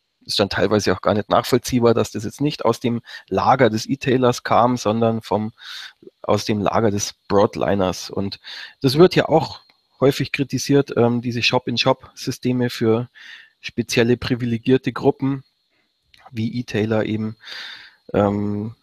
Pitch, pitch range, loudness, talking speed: 120 Hz, 110-130 Hz, -20 LUFS, 135 wpm